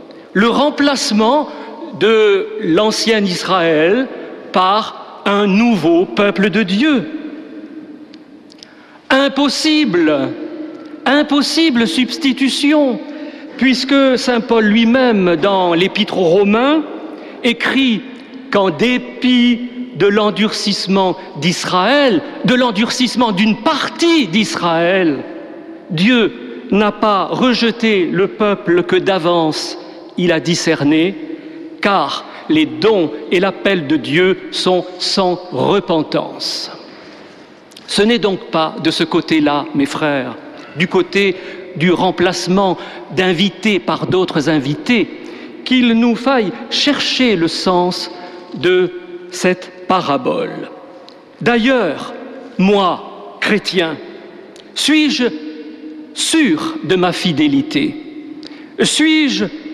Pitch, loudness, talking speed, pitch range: 235 Hz, -14 LUFS, 90 wpm, 185-295 Hz